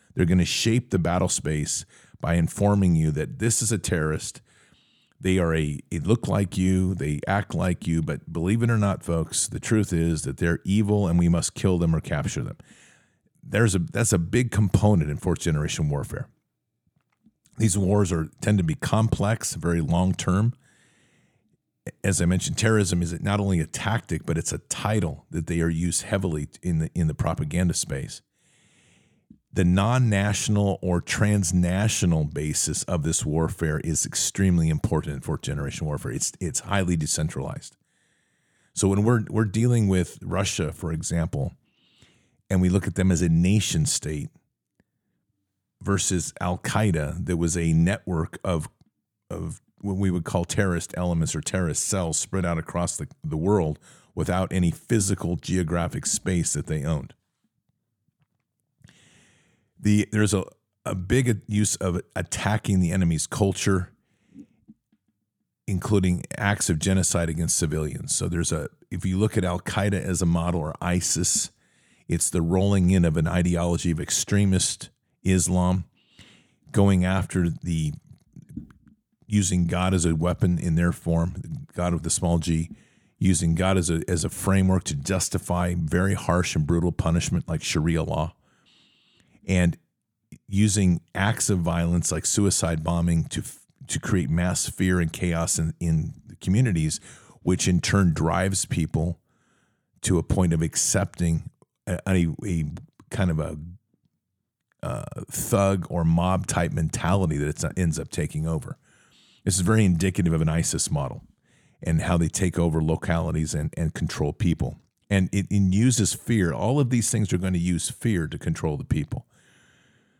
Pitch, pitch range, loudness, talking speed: 90 Hz, 85-100 Hz, -24 LUFS, 155 wpm